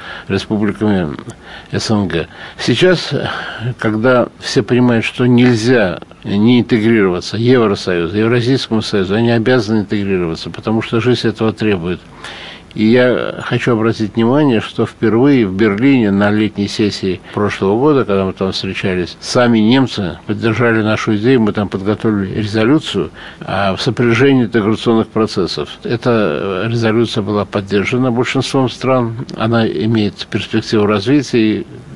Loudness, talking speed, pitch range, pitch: -14 LUFS, 115 wpm, 100-120 Hz, 110 Hz